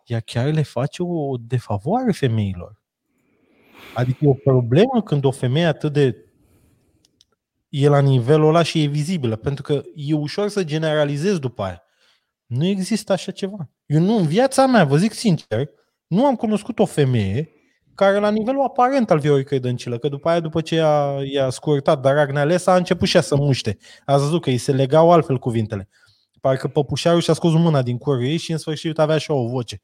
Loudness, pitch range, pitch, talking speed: -19 LUFS, 135-175 Hz, 150 Hz, 185 wpm